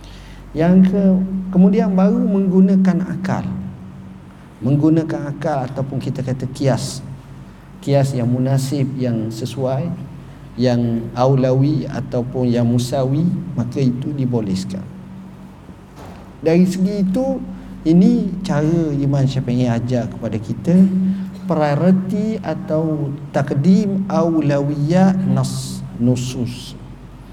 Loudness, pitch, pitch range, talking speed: -18 LUFS, 140 Hz, 125-180 Hz, 90 wpm